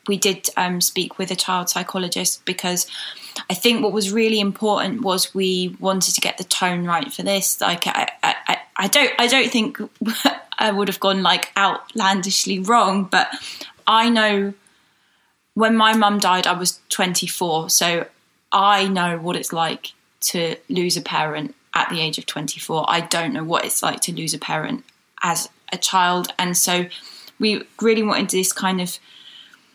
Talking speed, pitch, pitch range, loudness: 175 wpm, 190 Hz, 180-215 Hz, -19 LUFS